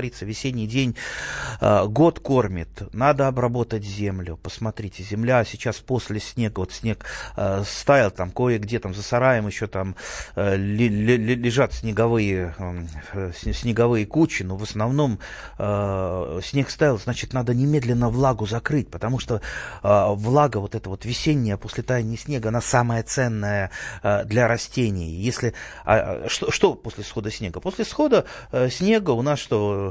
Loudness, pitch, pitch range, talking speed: -23 LUFS, 115 Hz, 100-125 Hz, 130 wpm